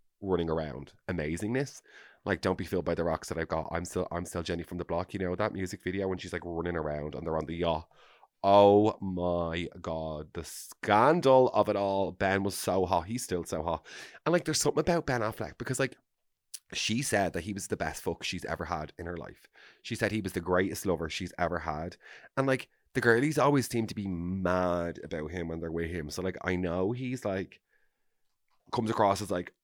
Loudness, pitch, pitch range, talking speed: -31 LUFS, 95 Hz, 85-105 Hz, 225 wpm